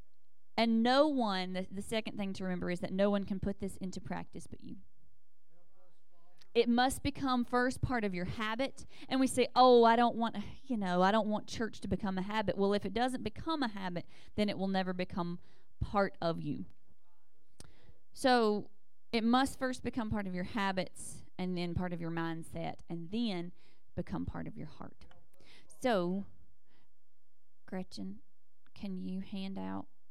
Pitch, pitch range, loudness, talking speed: 195 Hz, 180-230 Hz, -34 LUFS, 175 wpm